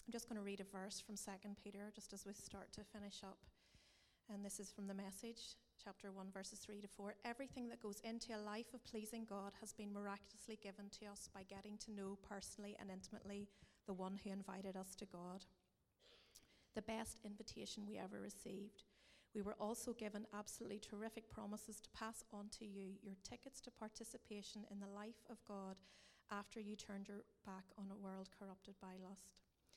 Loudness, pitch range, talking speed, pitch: -54 LUFS, 195-215 Hz, 195 wpm, 205 Hz